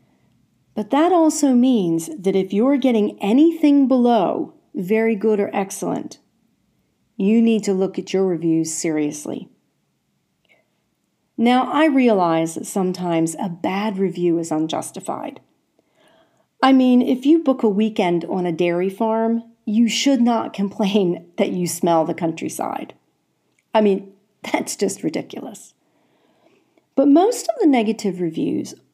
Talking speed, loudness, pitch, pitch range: 130 wpm, -19 LUFS, 210 Hz, 175-250 Hz